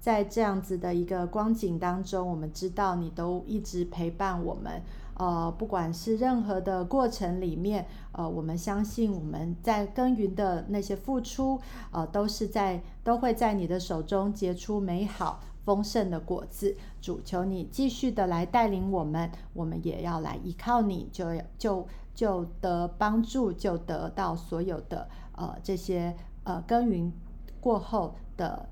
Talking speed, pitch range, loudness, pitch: 230 characters per minute, 175-210 Hz, -31 LUFS, 190 Hz